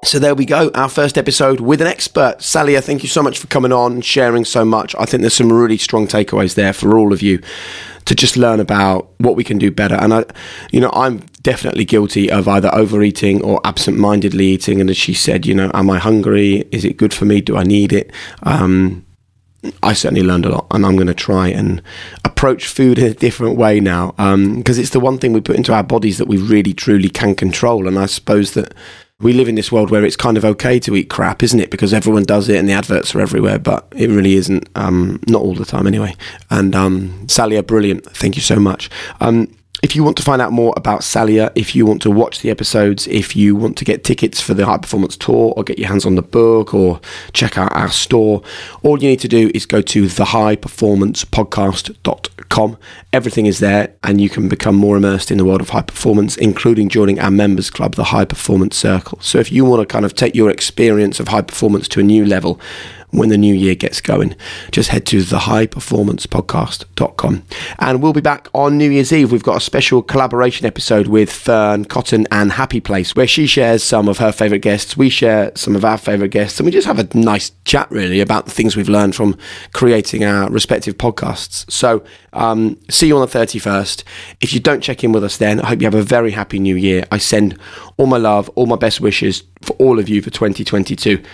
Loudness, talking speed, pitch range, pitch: -13 LUFS, 230 wpm, 100-115 Hz, 105 Hz